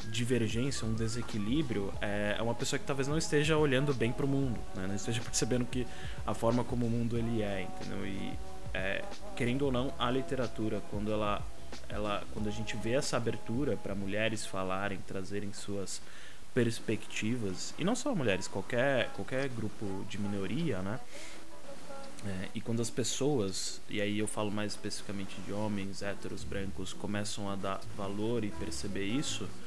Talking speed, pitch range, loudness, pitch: 165 wpm, 100-120 Hz, -35 LUFS, 105 Hz